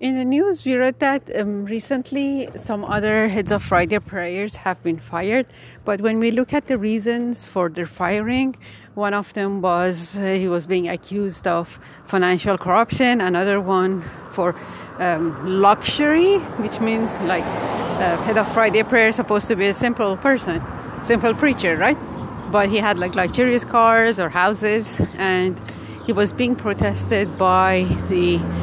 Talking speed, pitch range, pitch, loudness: 160 wpm, 180-230 Hz, 205 Hz, -20 LUFS